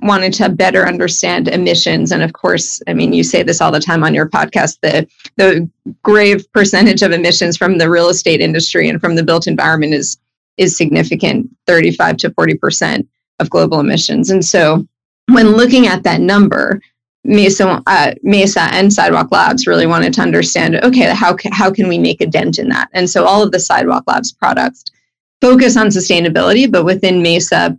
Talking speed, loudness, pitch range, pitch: 185 wpm, -11 LUFS, 170-210 Hz, 190 Hz